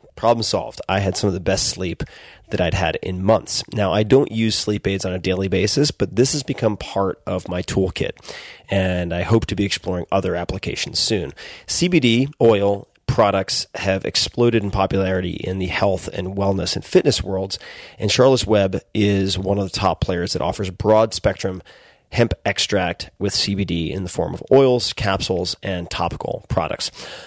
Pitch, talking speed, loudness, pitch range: 100 Hz, 180 wpm, -20 LUFS, 95-110 Hz